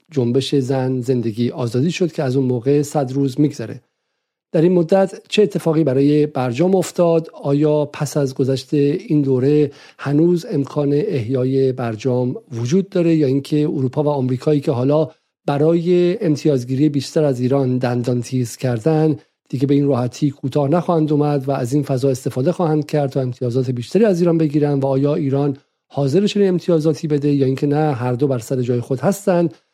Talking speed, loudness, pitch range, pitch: 170 wpm, -18 LUFS, 130-160 Hz, 145 Hz